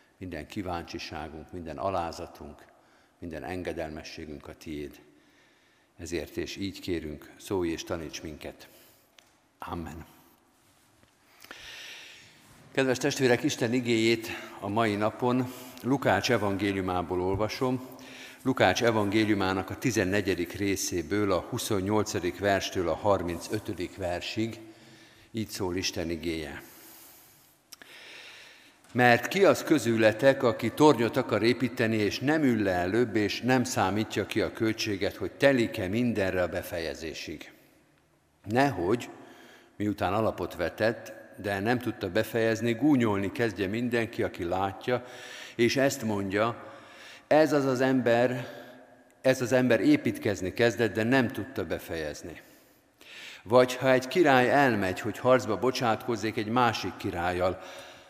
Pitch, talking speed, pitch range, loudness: 110 Hz, 110 wpm, 100-125 Hz, -28 LUFS